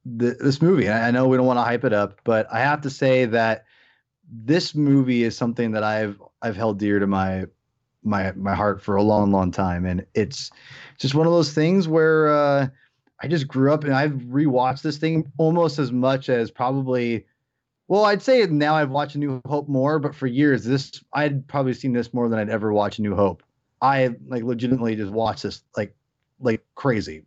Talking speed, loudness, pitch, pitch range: 205 wpm, -21 LUFS, 125 Hz, 110-145 Hz